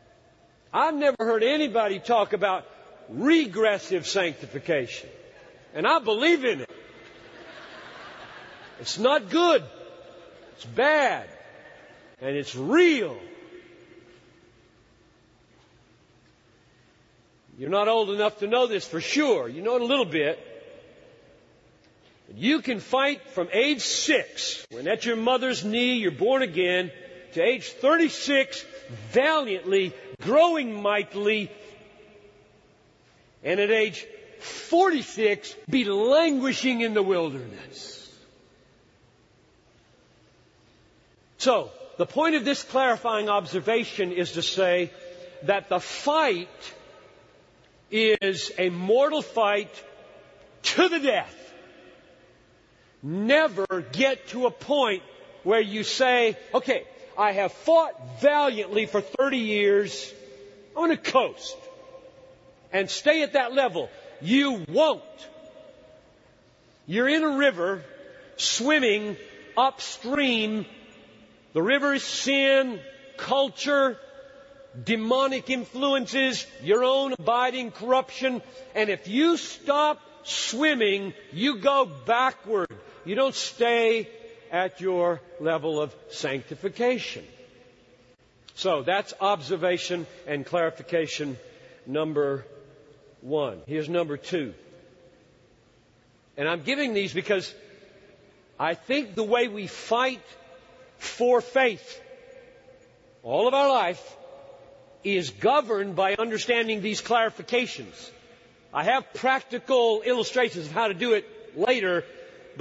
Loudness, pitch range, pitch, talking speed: -25 LUFS, 195-285 Hz, 235 Hz, 100 wpm